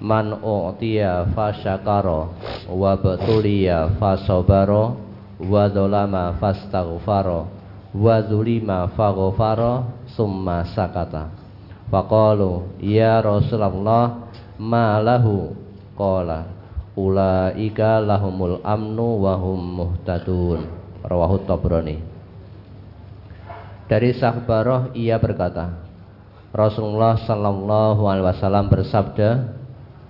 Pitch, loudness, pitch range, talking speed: 100 Hz, -20 LUFS, 95-110 Hz, 70 wpm